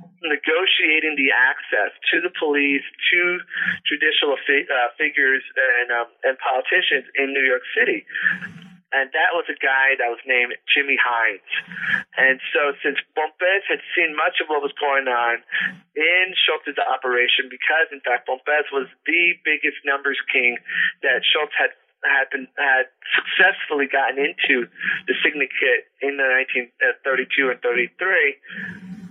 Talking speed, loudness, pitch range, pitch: 145 wpm, -19 LUFS, 135-185 Hz, 155 Hz